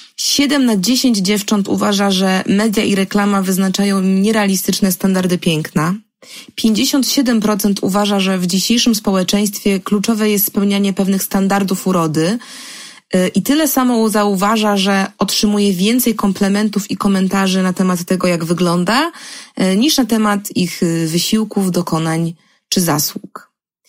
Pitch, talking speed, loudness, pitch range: 205 Hz, 120 wpm, -15 LUFS, 190-220 Hz